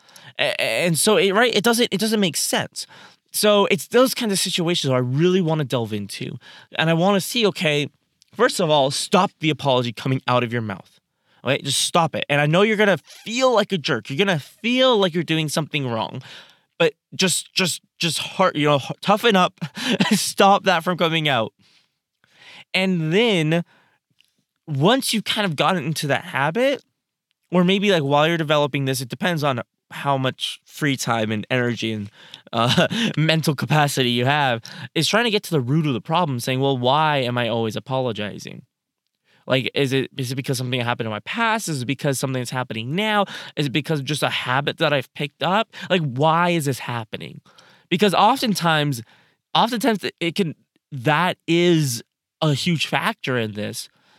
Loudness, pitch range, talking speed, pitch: -20 LUFS, 135-190 Hz, 185 wpm, 155 Hz